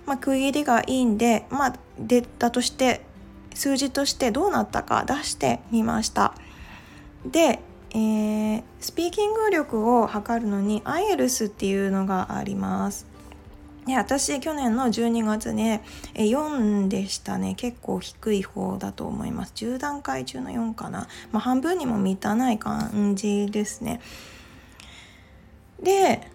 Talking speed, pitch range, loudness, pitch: 250 characters per minute, 205-265 Hz, -25 LUFS, 230 Hz